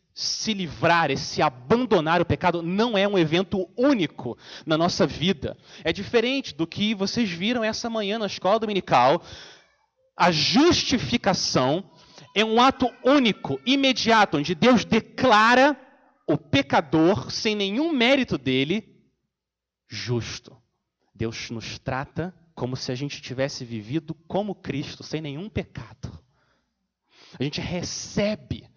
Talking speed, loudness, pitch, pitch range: 125 wpm, -23 LUFS, 190 Hz, 155-225 Hz